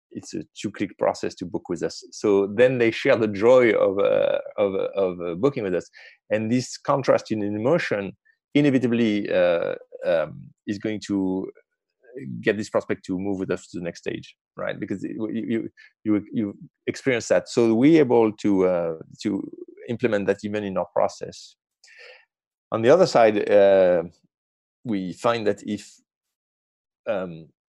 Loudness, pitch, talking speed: -23 LUFS, 105 Hz, 160 wpm